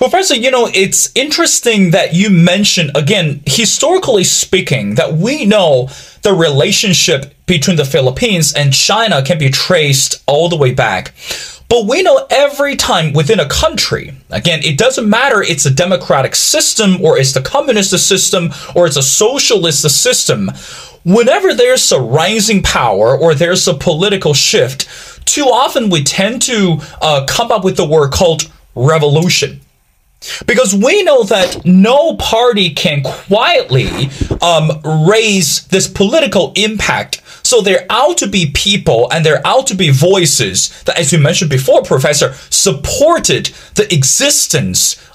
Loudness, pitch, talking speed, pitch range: -10 LUFS, 180 Hz, 150 wpm, 155-220 Hz